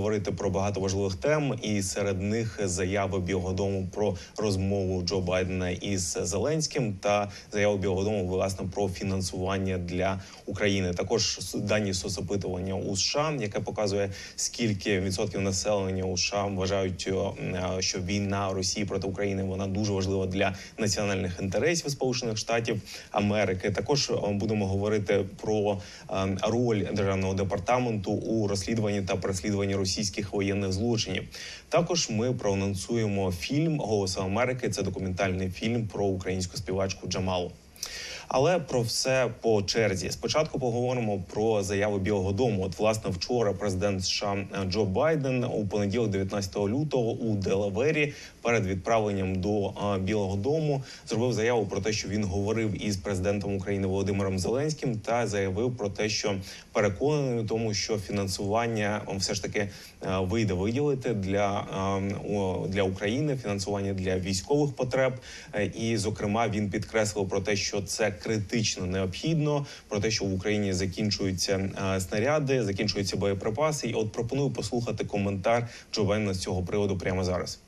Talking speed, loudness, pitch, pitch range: 135 wpm, -28 LUFS, 100 Hz, 95-110 Hz